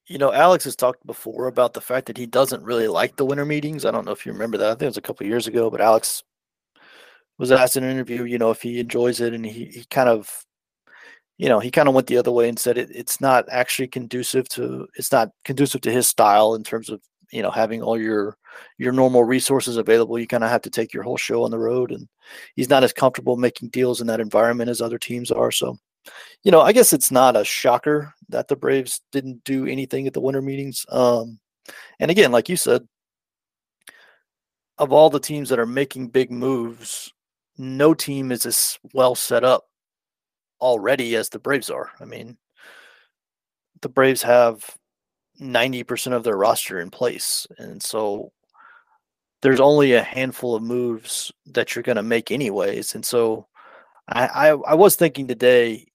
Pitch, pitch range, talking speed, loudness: 125 Hz, 120-135 Hz, 205 wpm, -20 LUFS